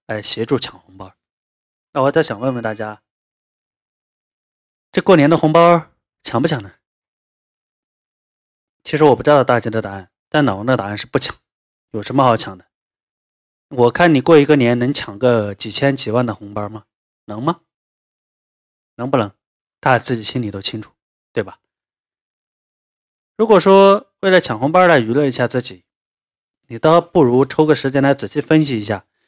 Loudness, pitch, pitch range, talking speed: -15 LUFS, 125 Hz, 105-150 Hz, 235 characters per minute